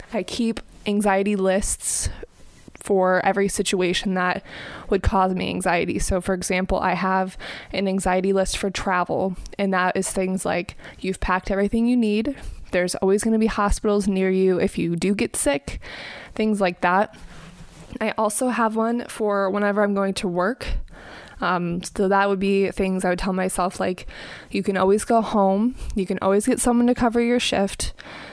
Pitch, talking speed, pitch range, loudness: 195 Hz, 175 wpm, 190-215 Hz, -22 LUFS